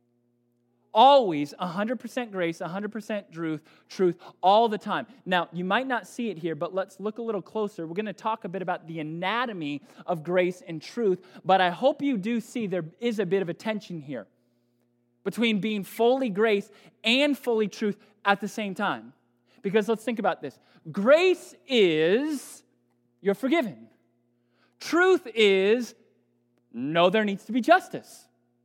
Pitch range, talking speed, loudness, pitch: 165-230 Hz, 160 wpm, -26 LUFS, 200 Hz